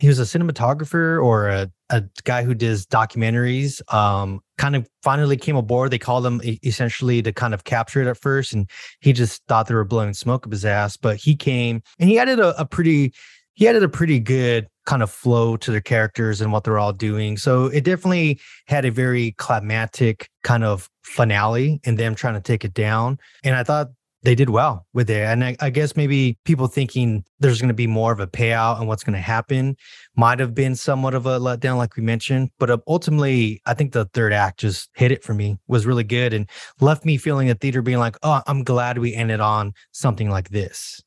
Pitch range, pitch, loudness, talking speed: 110-135 Hz, 120 Hz, -20 LUFS, 220 wpm